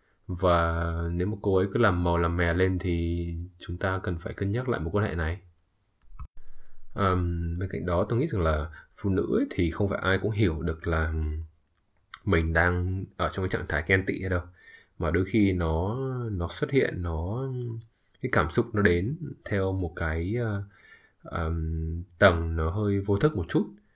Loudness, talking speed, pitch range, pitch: -28 LUFS, 195 wpm, 85-100 Hz, 90 Hz